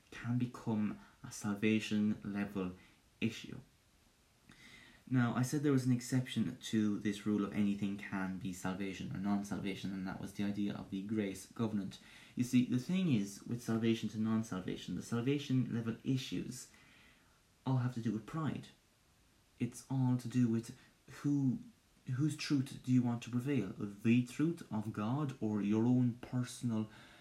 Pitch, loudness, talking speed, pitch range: 115 Hz, -37 LUFS, 165 wpm, 105-125 Hz